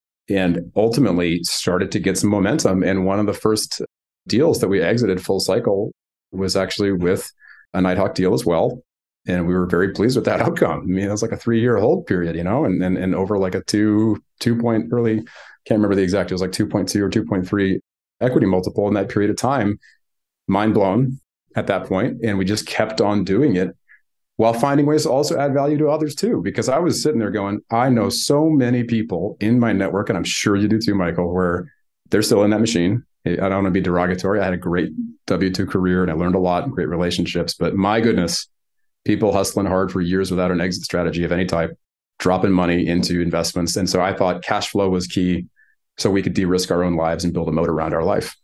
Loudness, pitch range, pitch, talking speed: -19 LUFS, 90-105 Hz, 95 Hz, 230 wpm